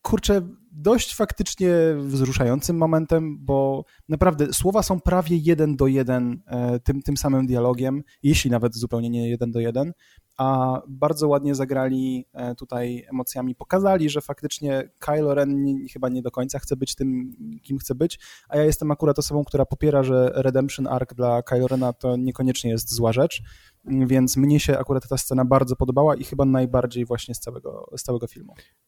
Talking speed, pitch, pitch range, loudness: 170 wpm, 135 Hz, 125-150 Hz, -22 LUFS